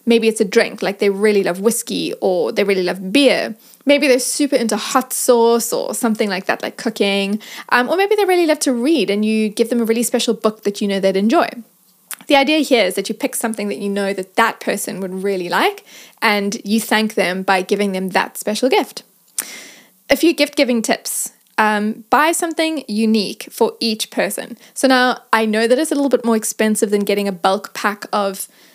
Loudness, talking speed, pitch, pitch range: -17 LUFS, 215 wpm, 225 Hz, 205-255 Hz